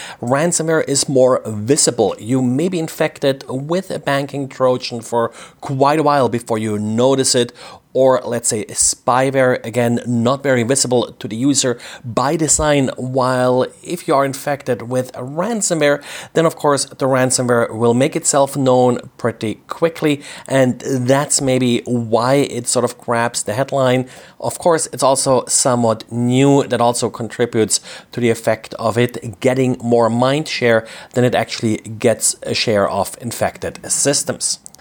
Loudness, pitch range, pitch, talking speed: -16 LUFS, 120-140 Hz, 130 Hz, 155 wpm